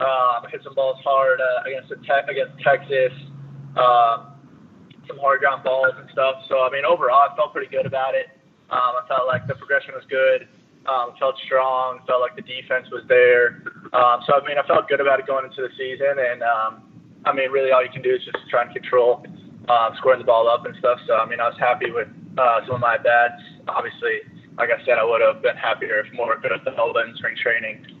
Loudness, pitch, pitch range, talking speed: -20 LUFS, 135 Hz, 130-185 Hz, 235 wpm